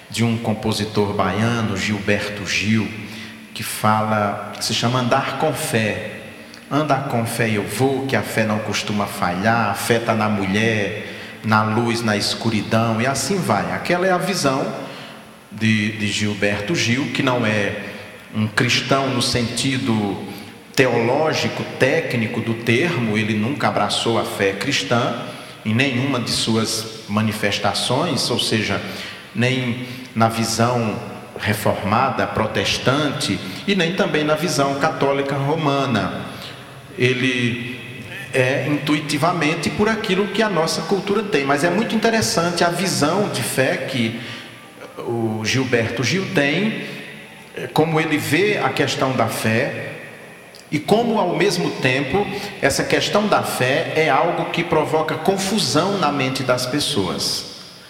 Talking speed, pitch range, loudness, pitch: 135 wpm, 110-145 Hz, -19 LUFS, 120 Hz